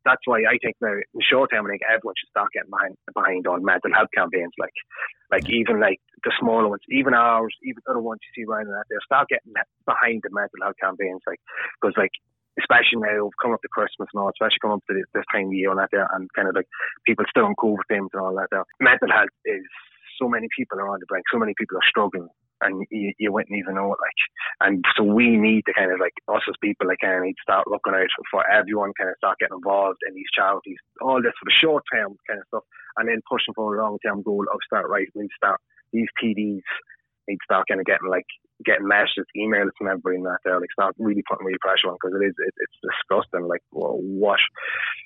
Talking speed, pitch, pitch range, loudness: 250 wpm, 105 Hz, 95-110 Hz, -22 LUFS